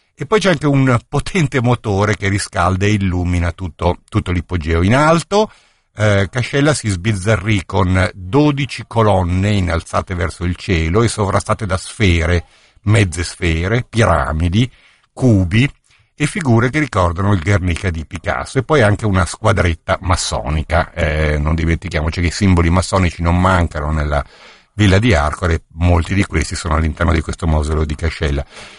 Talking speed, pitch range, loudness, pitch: 150 wpm, 85-110 Hz, -16 LUFS, 95 Hz